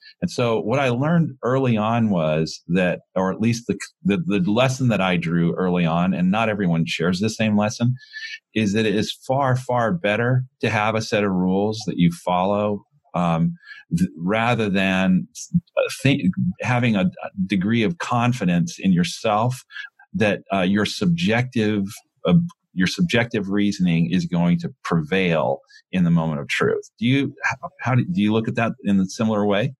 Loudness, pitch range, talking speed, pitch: -21 LUFS, 95-140 Hz, 175 wpm, 115 Hz